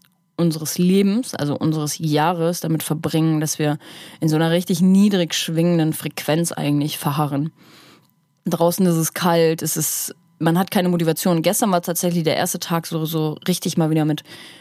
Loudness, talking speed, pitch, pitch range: -20 LUFS, 160 wpm, 165 Hz, 155-175 Hz